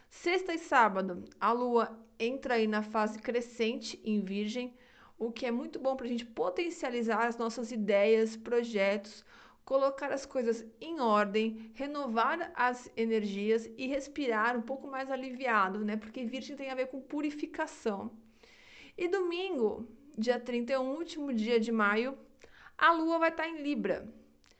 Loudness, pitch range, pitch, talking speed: -32 LUFS, 225-275 Hz, 240 Hz, 150 wpm